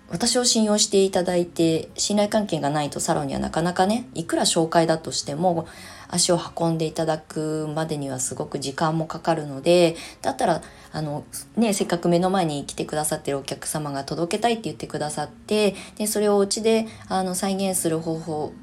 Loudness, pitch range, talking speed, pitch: -23 LUFS, 155-195 Hz, 385 characters per minute, 165 Hz